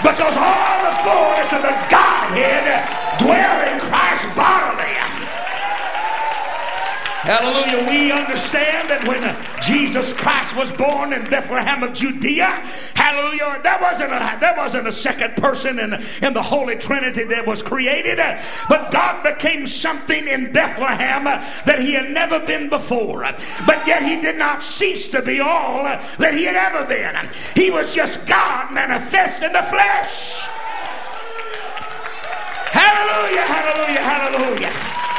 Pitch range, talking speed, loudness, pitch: 260-325 Hz, 135 wpm, -17 LUFS, 285 Hz